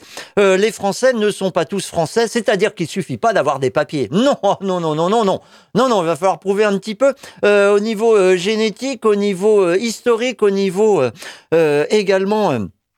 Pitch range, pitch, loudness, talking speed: 185-220 Hz, 200 Hz, -16 LUFS, 215 wpm